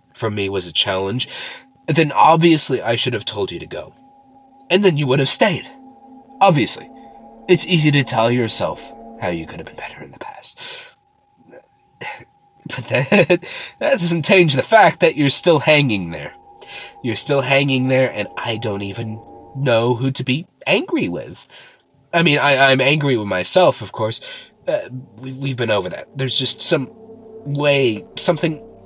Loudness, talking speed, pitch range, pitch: -16 LUFS, 170 wpm, 115-175 Hz, 135 Hz